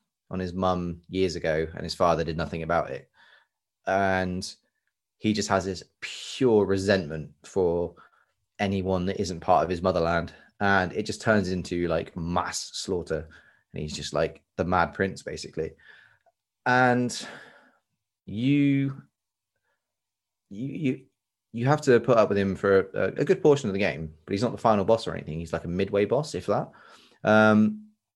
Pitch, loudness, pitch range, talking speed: 95 Hz, -26 LUFS, 90-110 Hz, 165 wpm